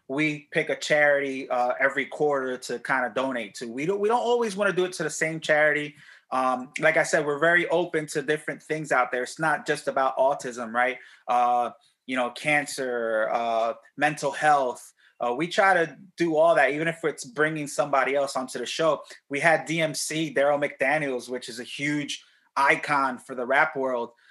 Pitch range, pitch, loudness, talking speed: 130-155 Hz, 145 Hz, -25 LUFS, 200 wpm